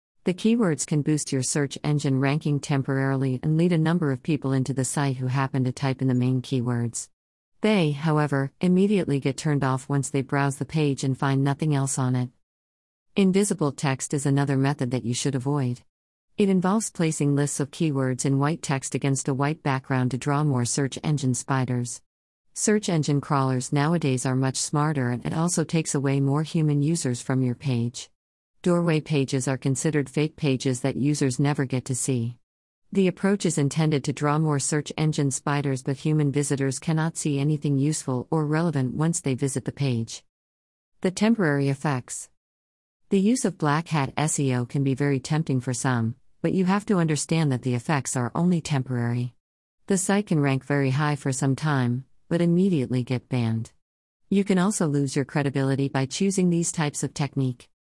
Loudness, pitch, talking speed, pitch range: -25 LUFS, 140 Hz, 185 wpm, 130-155 Hz